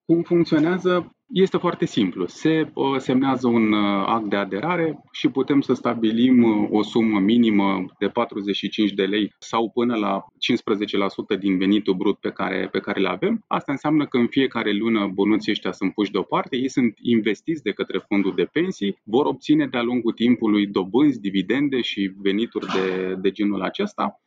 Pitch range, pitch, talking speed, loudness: 100-140 Hz, 115 Hz, 170 wpm, -22 LUFS